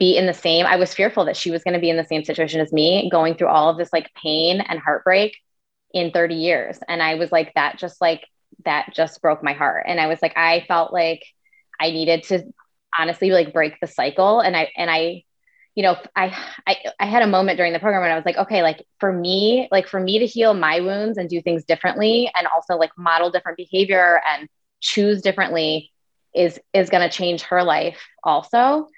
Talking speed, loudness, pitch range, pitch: 225 wpm, -19 LUFS, 165-190 Hz, 175 Hz